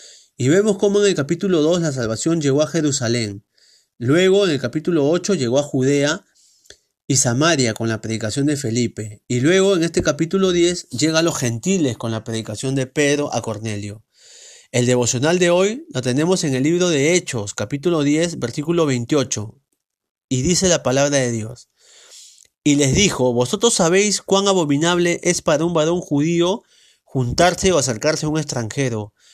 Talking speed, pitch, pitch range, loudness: 170 wpm, 150 Hz, 125-175 Hz, -18 LUFS